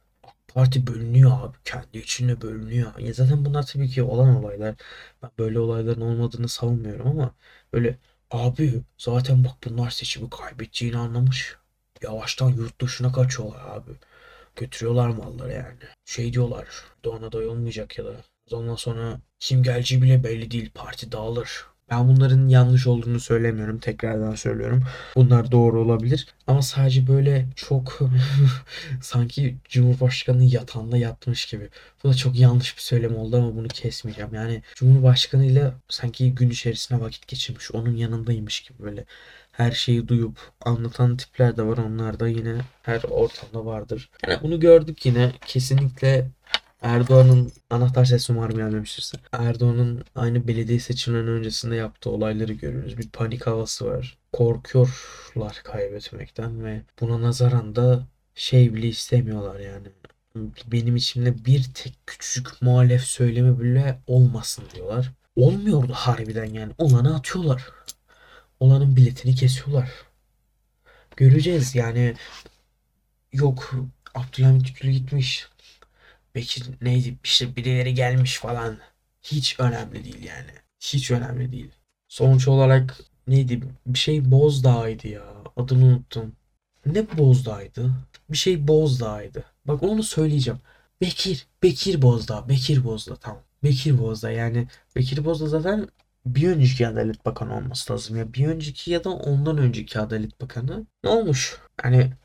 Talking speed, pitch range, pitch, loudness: 130 wpm, 115-130 Hz, 125 Hz, -22 LUFS